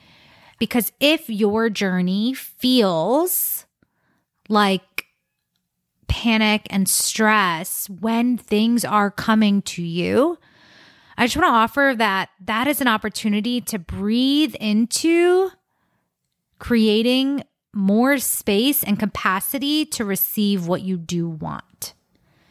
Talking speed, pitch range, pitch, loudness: 105 wpm, 195-245 Hz, 220 Hz, -19 LUFS